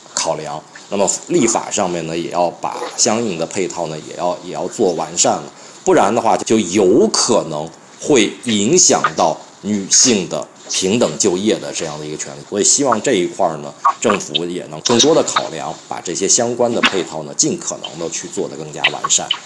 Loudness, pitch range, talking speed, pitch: -16 LUFS, 75-105 Hz, 280 characters per minute, 85 Hz